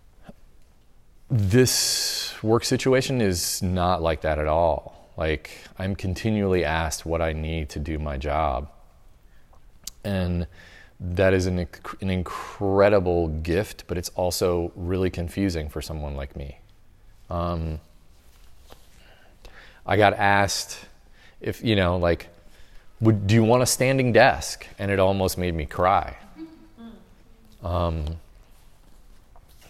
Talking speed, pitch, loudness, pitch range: 115 wpm, 90 Hz, -24 LUFS, 80-100 Hz